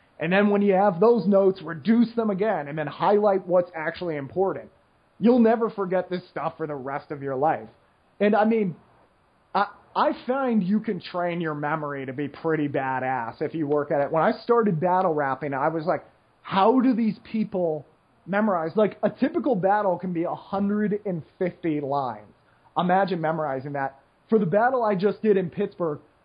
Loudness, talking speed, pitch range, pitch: -24 LUFS, 180 wpm, 155-210 Hz, 185 Hz